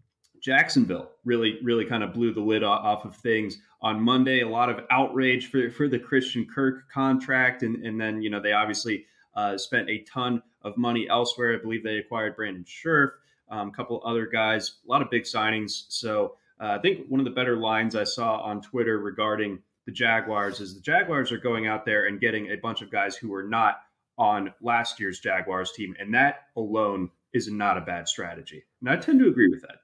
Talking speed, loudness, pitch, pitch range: 210 wpm, -26 LUFS, 115 Hz, 105-125 Hz